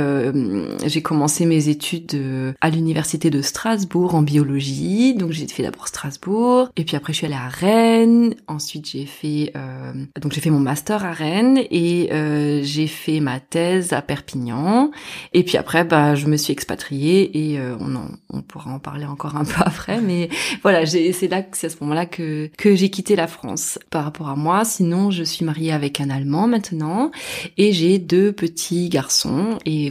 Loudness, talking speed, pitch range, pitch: -19 LUFS, 195 wpm, 150-185 Hz, 160 Hz